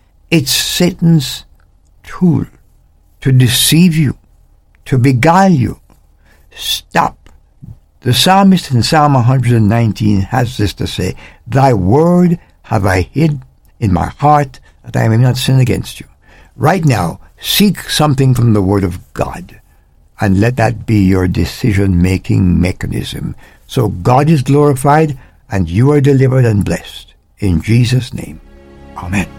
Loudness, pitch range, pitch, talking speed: -12 LUFS, 90-140 Hz, 115 Hz, 130 wpm